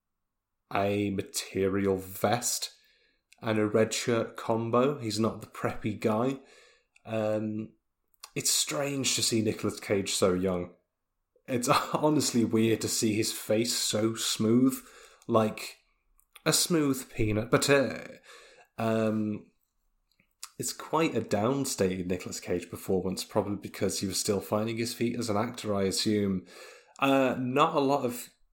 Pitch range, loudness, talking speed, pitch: 100-120 Hz, -29 LUFS, 135 wpm, 110 Hz